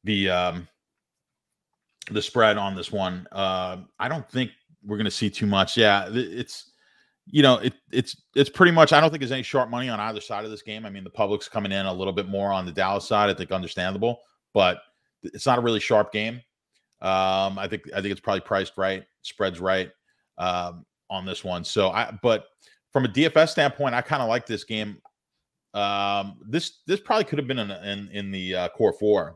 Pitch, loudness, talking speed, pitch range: 105 Hz, -24 LUFS, 215 wpm, 95-125 Hz